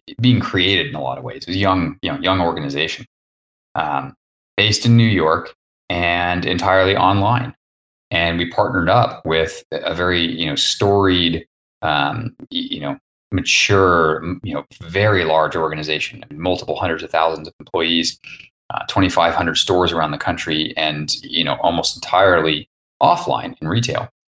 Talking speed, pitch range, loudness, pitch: 155 wpm, 80-95 Hz, -18 LUFS, 85 Hz